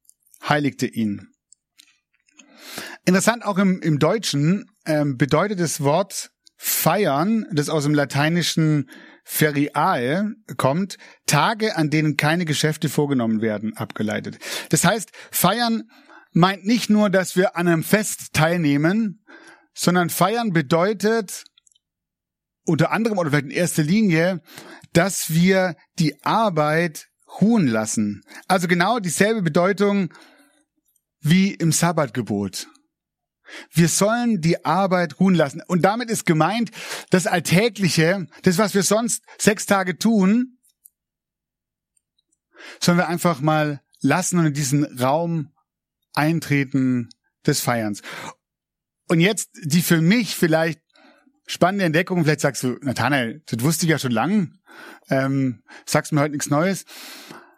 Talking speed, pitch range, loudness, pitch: 120 wpm, 150-200 Hz, -20 LUFS, 170 Hz